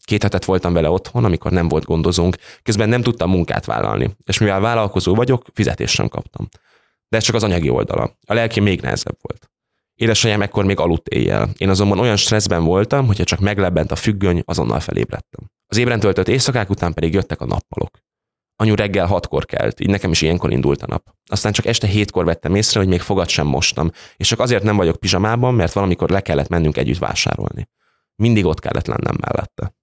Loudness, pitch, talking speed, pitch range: -17 LUFS, 100 Hz, 195 wpm, 90-110 Hz